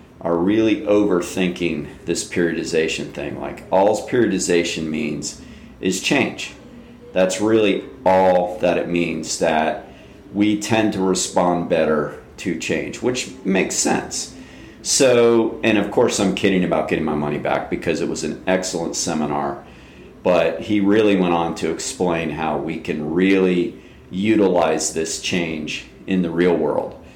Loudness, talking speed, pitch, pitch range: -19 LUFS, 140 wpm, 90 Hz, 80-95 Hz